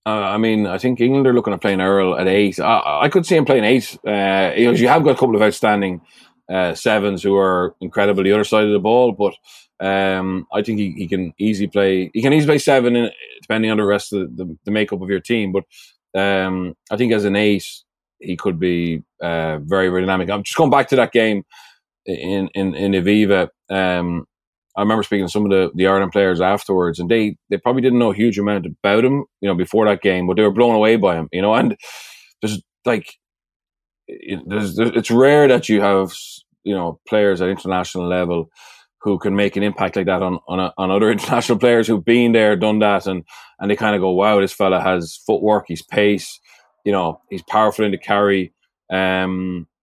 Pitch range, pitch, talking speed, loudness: 95-110 Hz, 100 Hz, 225 wpm, -17 LUFS